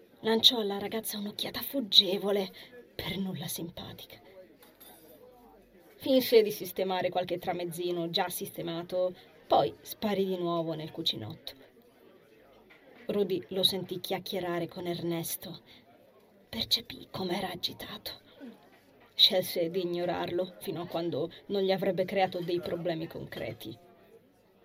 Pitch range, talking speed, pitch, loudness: 175-200 Hz, 105 wpm, 185 Hz, -30 LUFS